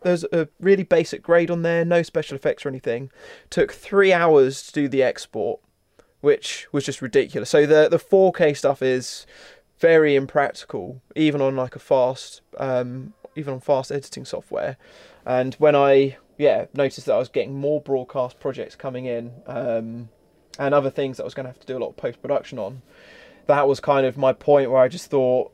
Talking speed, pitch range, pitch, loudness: 195 wpm, 130-155 Hz, 140 Hz, -21 LUFS